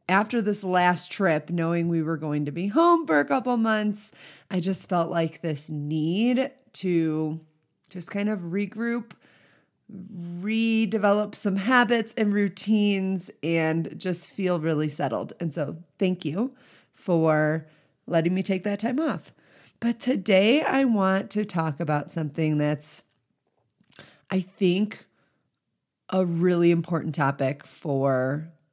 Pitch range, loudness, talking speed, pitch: 160-210 Hz, -25 LUFS, 130 wpm, 180 Hz